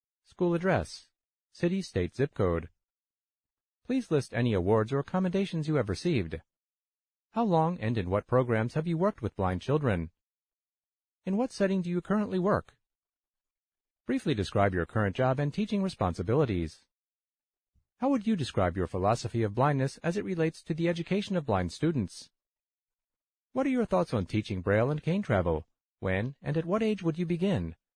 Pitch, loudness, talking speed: 145 Hz, -30 LUFS, 165 wpm